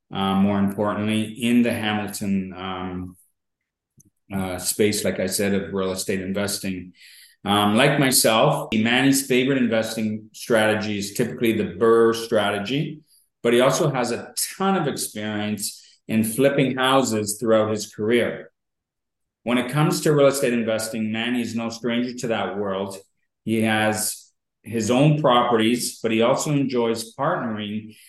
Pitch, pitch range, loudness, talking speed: 110 Hz, 105-125 Hz, -22 LUFS, 140 wpm